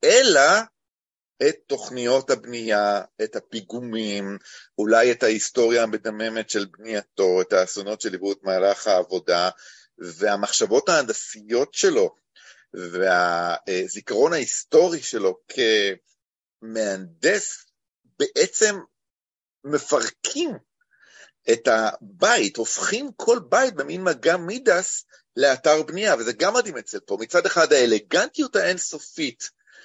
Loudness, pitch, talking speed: -22 LUFS, 155 Hz, 90 wpm